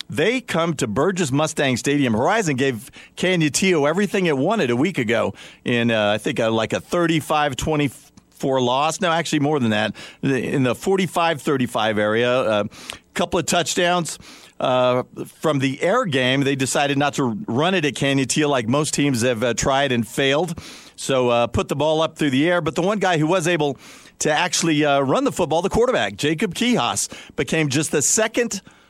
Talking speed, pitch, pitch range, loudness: 190 wpm, 150 Hz, 135-175 Hz, -20 LUFS